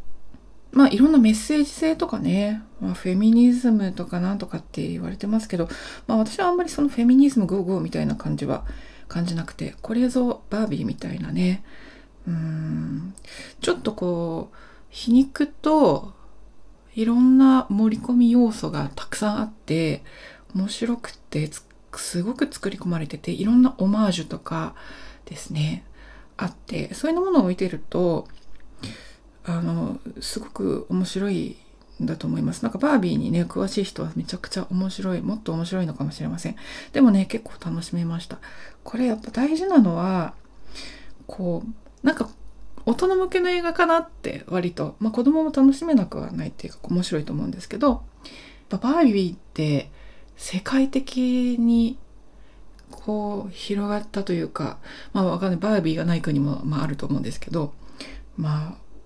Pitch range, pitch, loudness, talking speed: 175-250 Hz, 210 Hz, -23 LUFS, 330 characters per minute